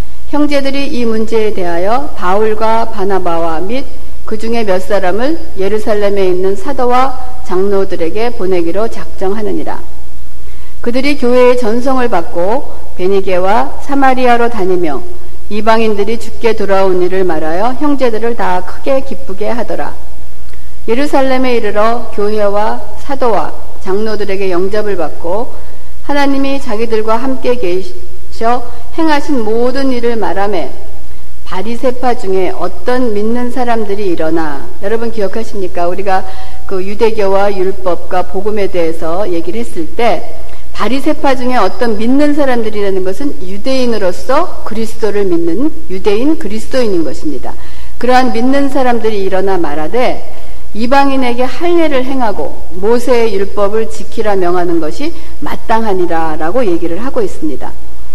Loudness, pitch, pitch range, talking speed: -14 LUFS, 220 Hz, 190-255 Hz, 305 characters per minute